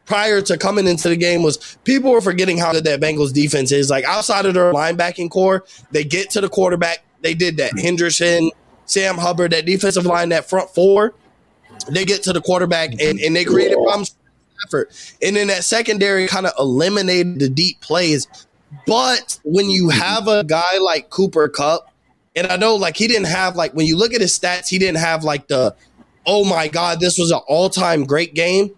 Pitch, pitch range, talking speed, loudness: 180 Hz, 165-195 Hz, 205 wpm, -16 LUFS